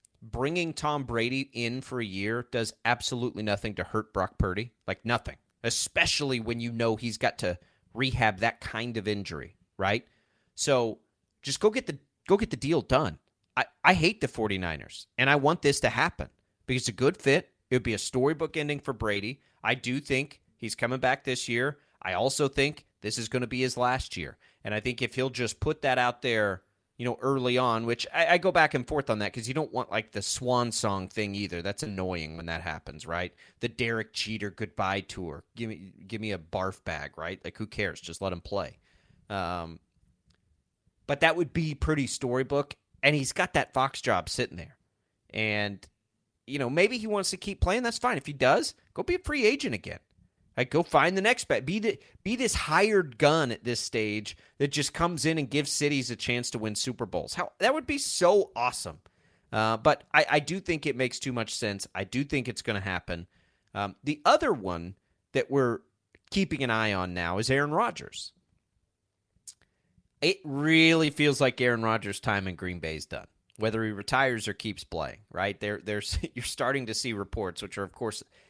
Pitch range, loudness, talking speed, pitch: 100-140 Hz, -29 LUFS, 205 wpm, 115 Hz